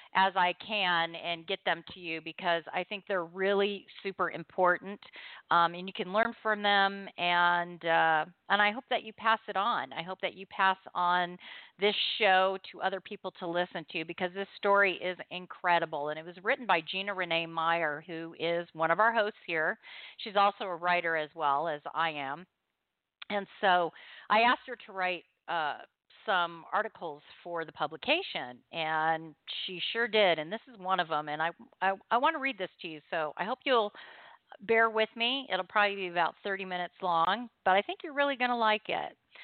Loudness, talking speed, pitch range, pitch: -30 LUFS, 200 wpm, 170-210 Hz, 185 Hz